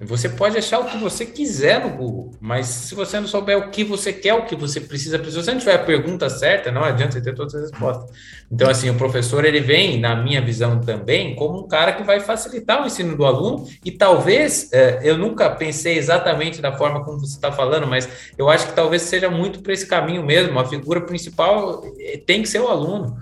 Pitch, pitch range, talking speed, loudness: 155 Hz, 130-195 Hz, 225 wpm, -19 LUFS